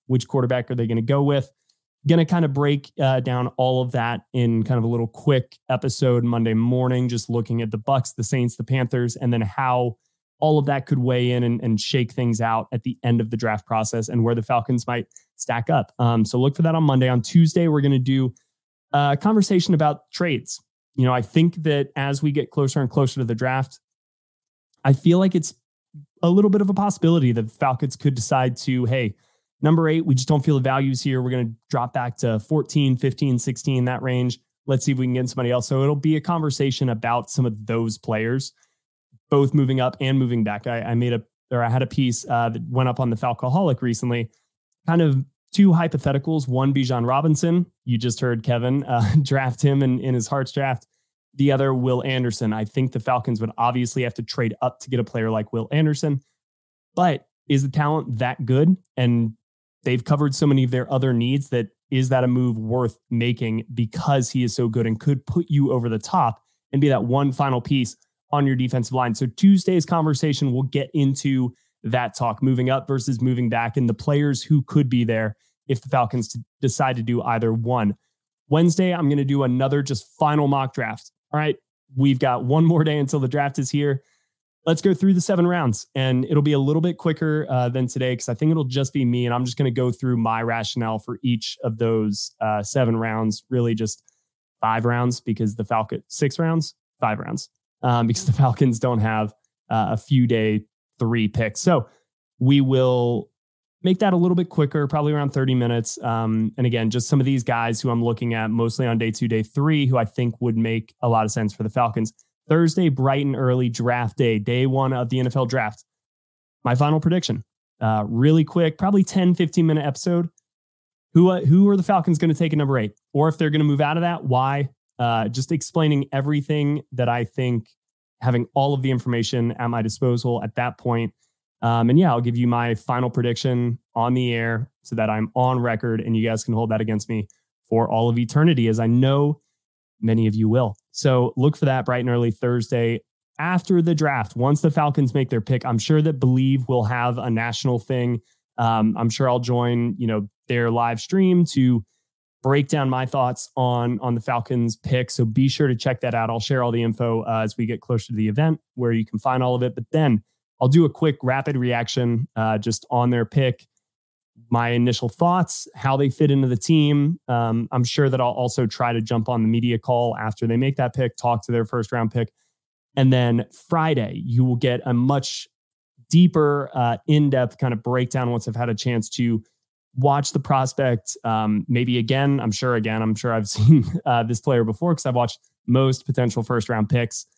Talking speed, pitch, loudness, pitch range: 215 wpm, 125 Hz, -21 LUFS, 115-140 Hz